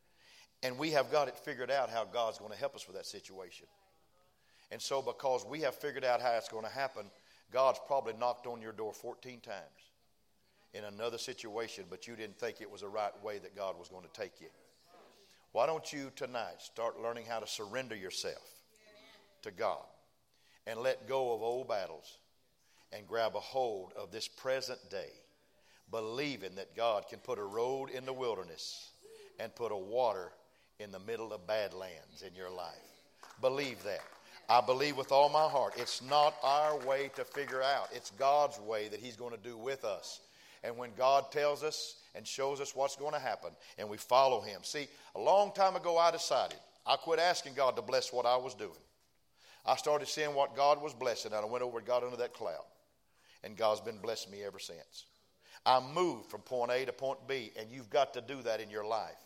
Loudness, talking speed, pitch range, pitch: -36 LUFS, 205 wpm, 115-150 Hz, 130 Hz